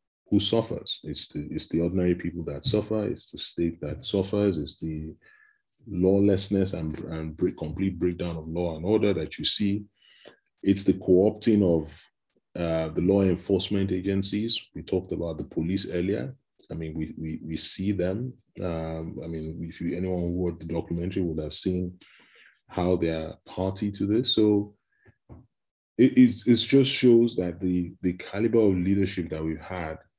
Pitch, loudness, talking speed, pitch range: 90 Hz, -26 LUFS, 175 wpm, 85-105 Hz